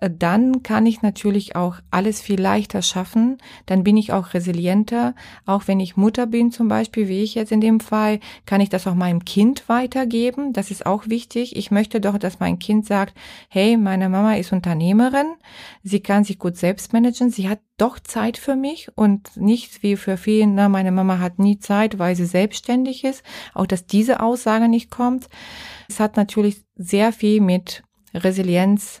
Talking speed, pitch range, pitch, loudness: 185 wpm, 190-230 Hz, 210 Hz, -19 LUFS